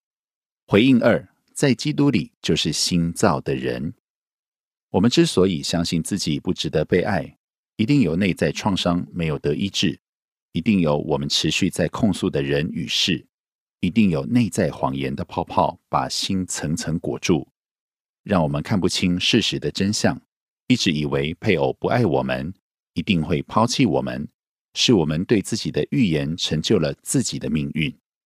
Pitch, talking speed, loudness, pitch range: 90 Hz, 240 characters per minute, -21 LUFS, 75-105 Hz